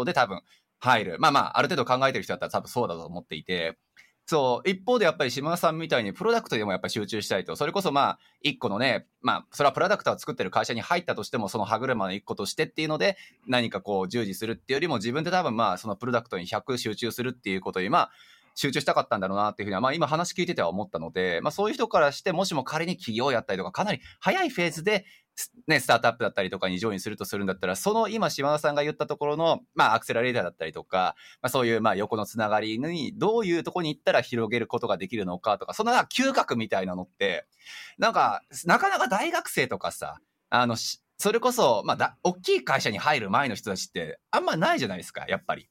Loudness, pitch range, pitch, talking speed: -26 LUFS, 110-175 Hz, 130 Hz, 510 characters per minute